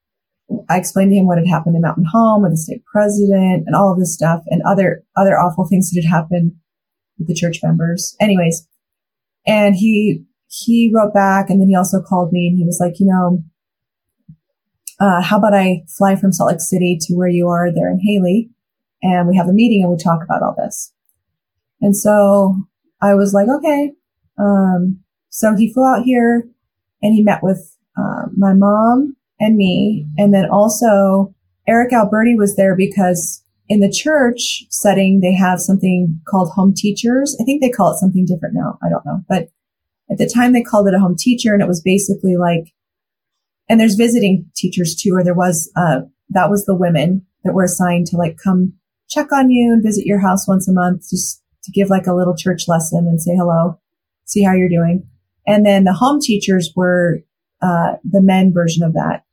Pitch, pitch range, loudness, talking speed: 190 Hz, 175-210 Hz, -14 LUFS, 200 wpm